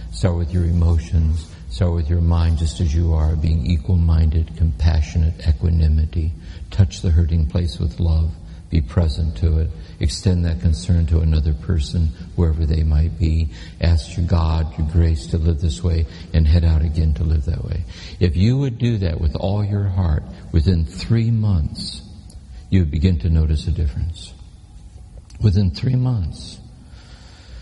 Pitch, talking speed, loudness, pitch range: 85 Hz, 165 wpm, -20 LUFS, 80-90 Hz